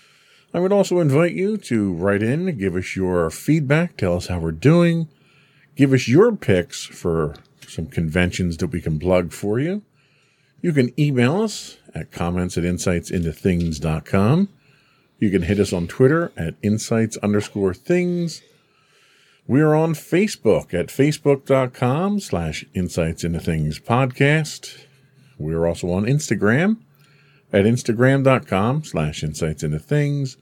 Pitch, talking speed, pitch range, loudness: 125 Hz, 130 wpm, 90-150 Hz, -20 LUFS